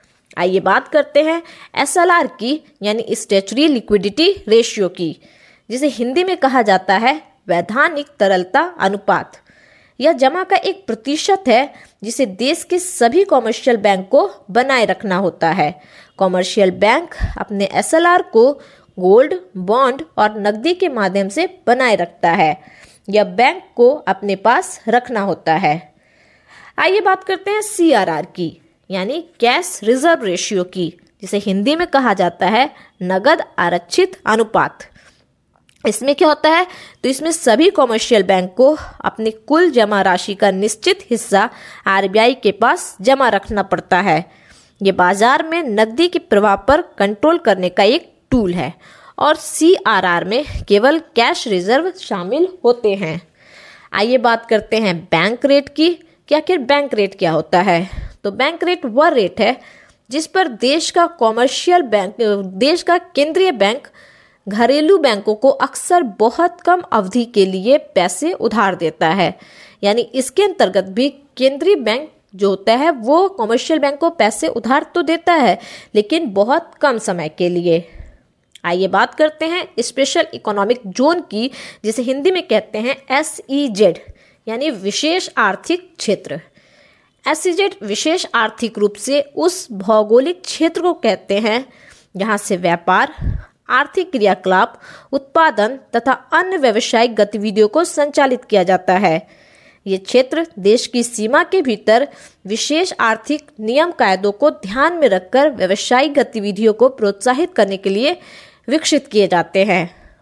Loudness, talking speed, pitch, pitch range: -15 LUFS, 145 wpm, 240 Hz, 200-310 Hz